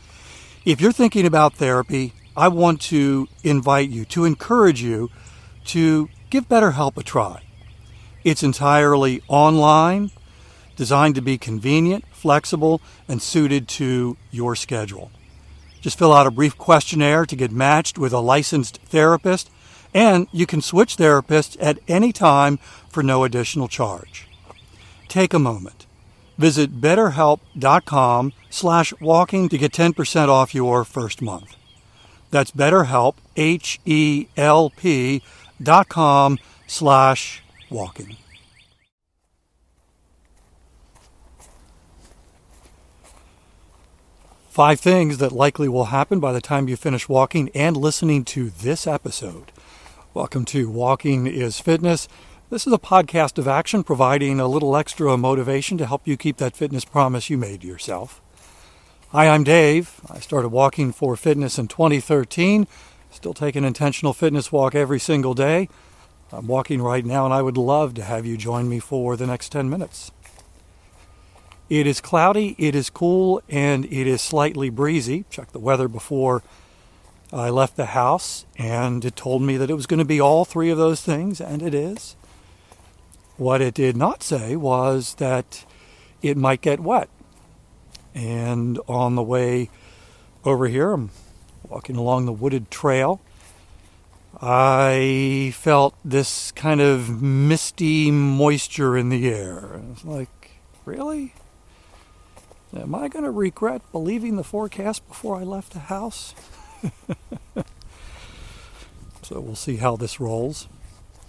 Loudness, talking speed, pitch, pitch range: -19 LUFS, 135 wpm, 135 Hz, 110-155 Hz